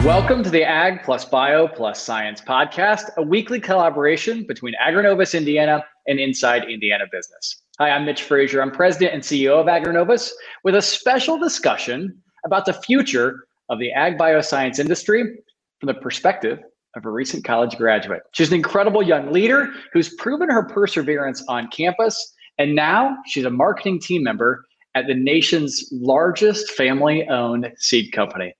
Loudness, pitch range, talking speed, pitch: -19 LUFS, 135-205 Hz, 155 wpm, 165 Hz